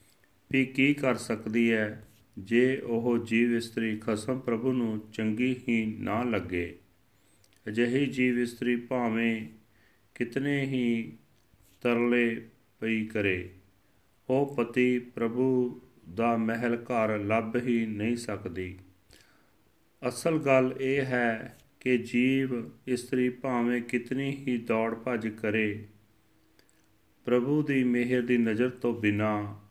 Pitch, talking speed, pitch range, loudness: 115 Hz, 110 wpm, 110-125 Hz, -29 LUFS